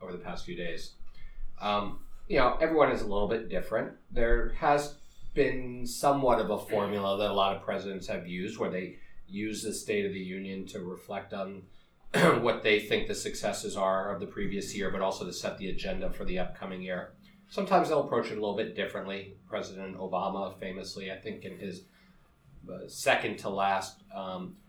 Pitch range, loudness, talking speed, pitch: 95-125 Hz, -31 LUFS, 190 wpm, 100 Hz